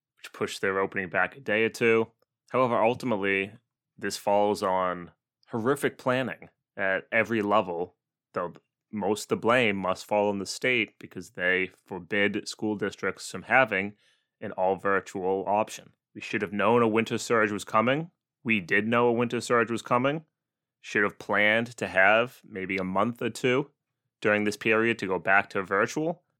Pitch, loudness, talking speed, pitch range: 110 Hz, -26 LUFS, 170 wpm, 100-120 Hz